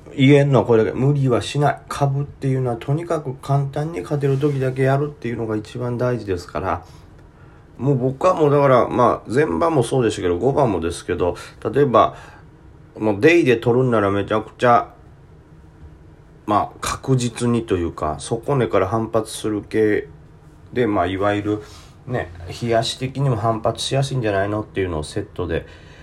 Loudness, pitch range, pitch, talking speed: -20 LUFS, 105-140 Hz, 120 Hz, 350 characters per minute